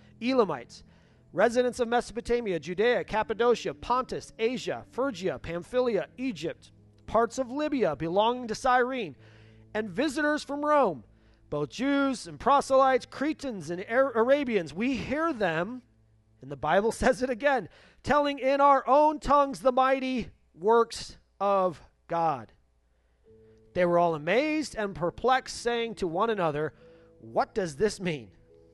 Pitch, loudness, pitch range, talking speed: 225 Hz, -27 LUFS, 165-260 Hz, 125 wpm